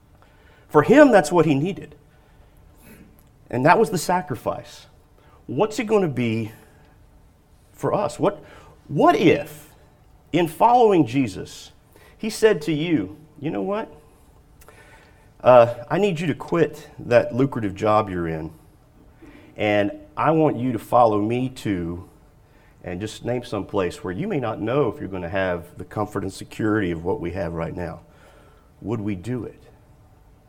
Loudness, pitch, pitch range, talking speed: -21 LUFS, 125 Hz, 105-150 Hz, 155 wpm